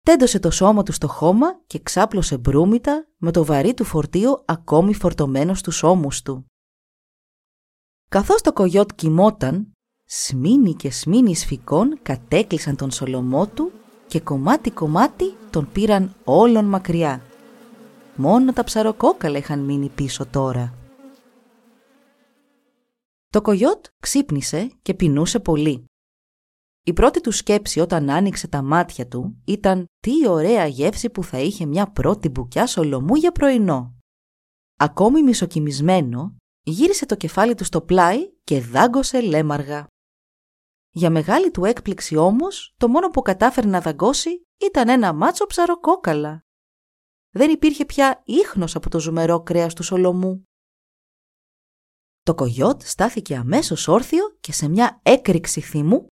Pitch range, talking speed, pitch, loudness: 155-250 Hz, 125 wpm, 190 Hz, -19 LUFS